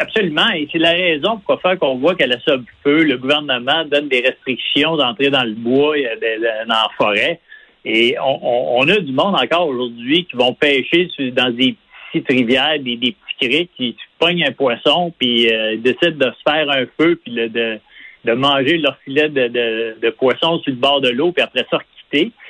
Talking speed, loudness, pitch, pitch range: 215 wpm, -16 LUFS, 135 Hz, 120-155 Hz